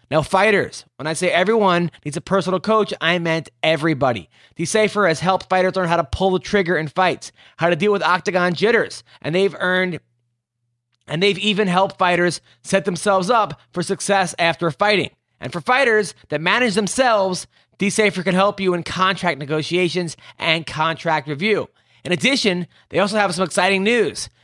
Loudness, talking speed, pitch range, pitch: -19 LUFS, 170 wpm, 160-200 Hz, 180 Hz